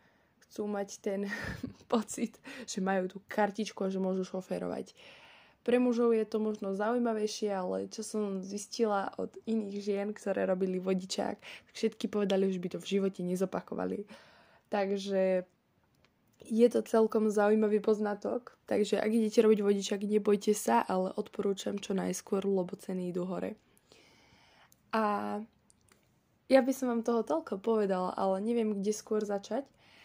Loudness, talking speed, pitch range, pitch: -32 LUFS, 140 wpm, 195-220 Hz, 205 Hz